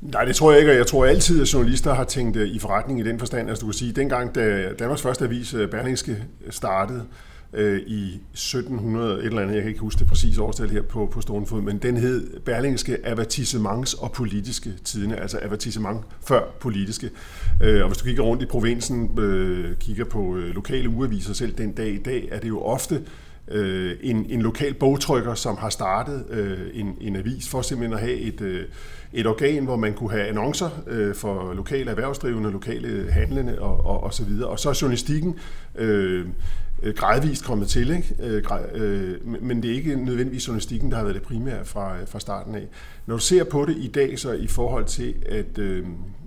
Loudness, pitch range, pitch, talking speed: -24 LUFS, 100-125 Hz, 110 Hz, 195 wpm